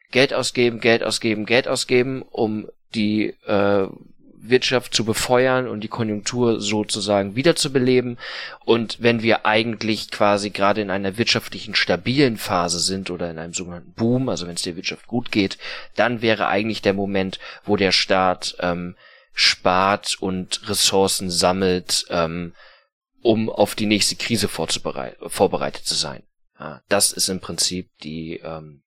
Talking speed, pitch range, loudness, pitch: 150 wpm, 90-115 Hz, -20 LUFS, 105 Hz